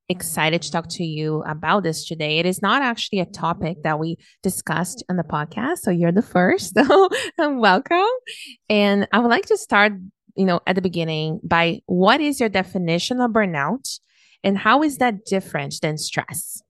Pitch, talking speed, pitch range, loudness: 190 Hz, 185 wpm, 165-230 Hz, -20 LUFS